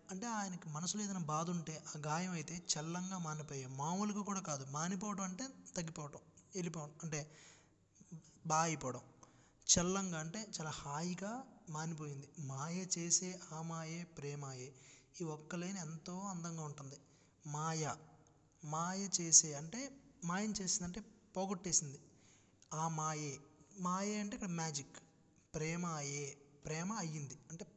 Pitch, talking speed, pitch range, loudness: 160 Hz, 115 wpm, 150-185 Hz, -40 LUFS